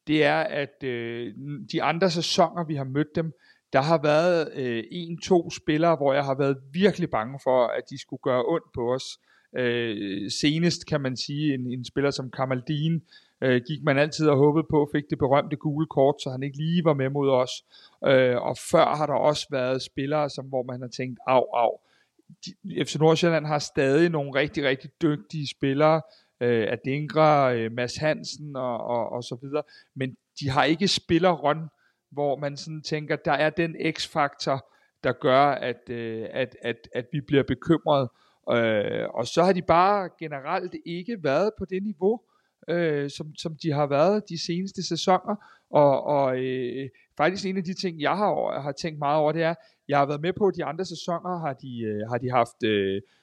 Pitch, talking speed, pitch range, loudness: 150 Hz, 190 wpm, 130-165 Hz, -25 LUFS